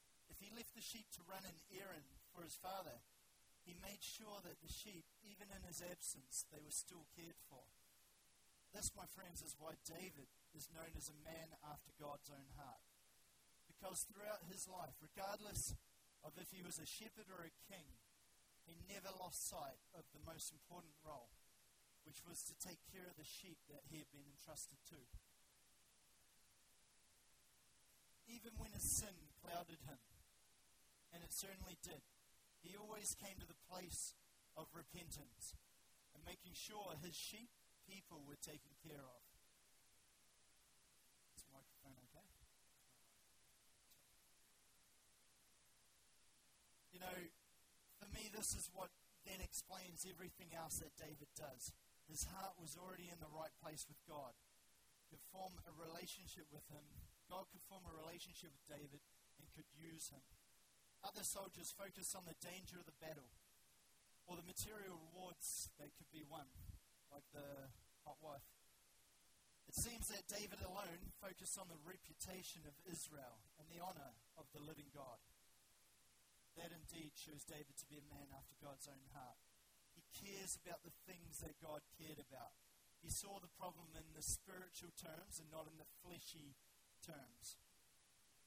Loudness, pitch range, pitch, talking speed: -54 LUFS, 145-185 Hz, 160 Hz, 155 wpm